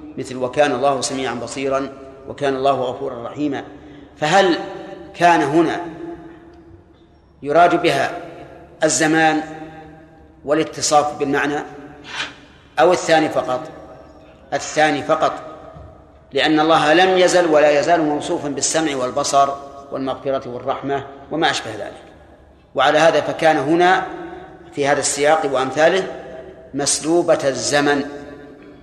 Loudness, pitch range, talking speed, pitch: -17 LUFS, 140-165 Hz, 95 wpm, 150 Hz